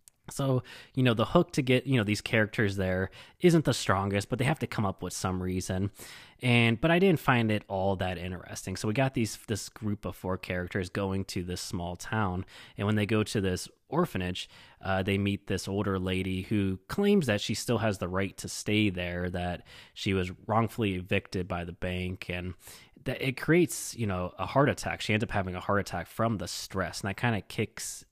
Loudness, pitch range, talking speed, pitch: -30 LUFS, 95-115 Hz, 220 wpm, 100 Hz